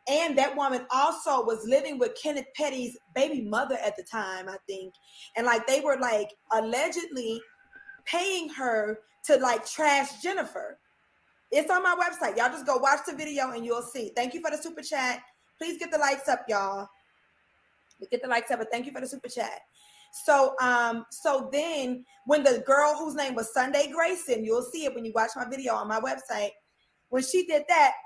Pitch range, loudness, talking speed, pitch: 235-305 Hz, -28 LUFS, 195 wpm, 270 Hz